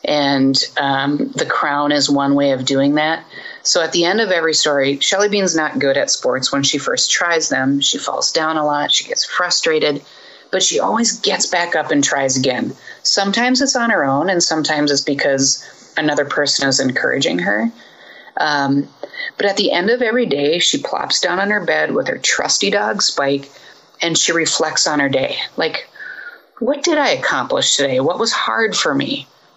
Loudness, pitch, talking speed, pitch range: -16 LUFS, 145 Hz, 195 wpm, 140-195 Hz